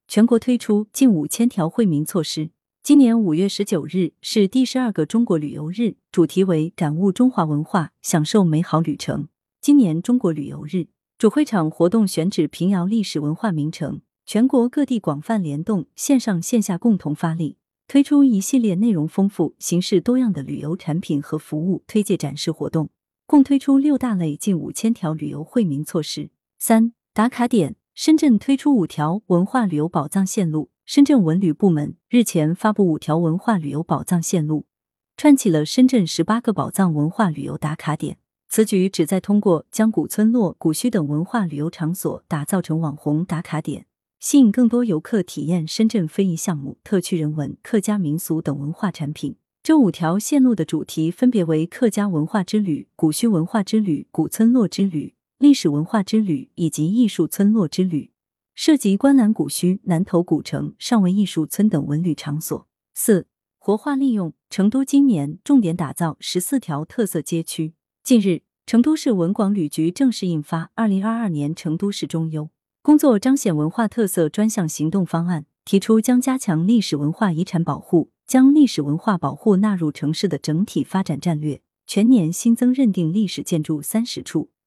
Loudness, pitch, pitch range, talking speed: -20 LUFS, 185 Hz, 160-225 Hz, 280 characters per minute